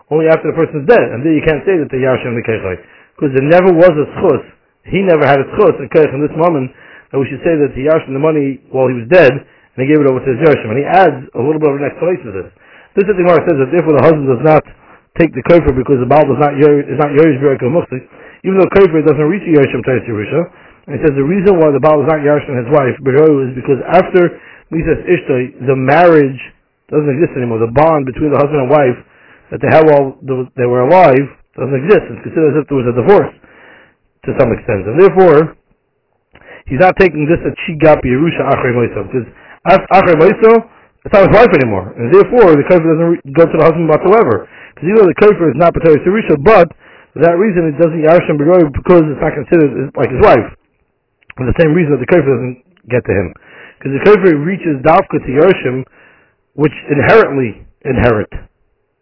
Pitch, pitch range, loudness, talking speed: 150 Hz, 135-170 Hz, -11 LUFS, 225 wpm